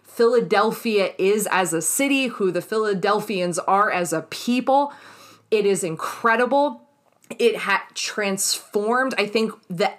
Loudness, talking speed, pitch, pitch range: -21 LUFS, 125 wpm, 210 Hz, 195-245 Hz